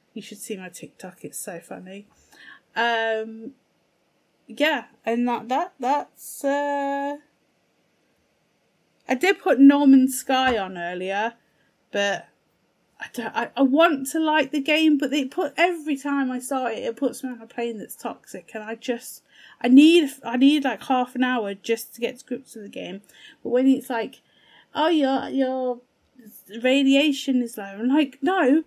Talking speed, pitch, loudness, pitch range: 165 wpm, 255 Hz, -22 LUFS, 230-280 Hz